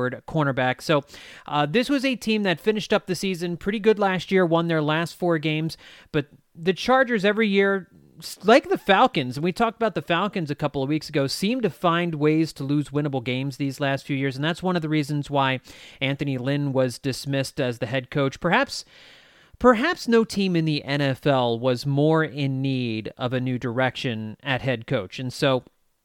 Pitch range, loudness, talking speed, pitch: 135-185 Hz, -23 LUFS, 200 wpm, 150 Hz